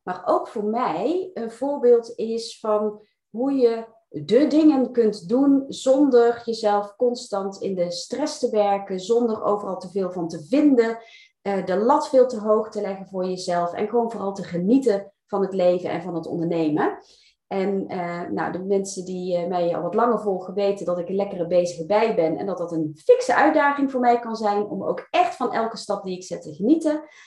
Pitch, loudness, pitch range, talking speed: 215 Hz, -22 LUFS, 185-245 Hz, 195 wpm